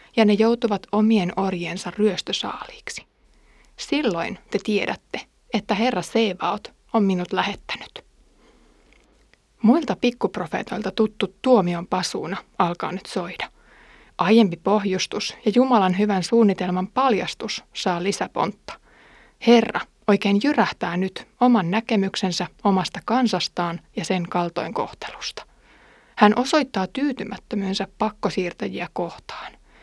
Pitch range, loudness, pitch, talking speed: 185-230 Hz, -22 LUFS, 205 Hz, 100 wpm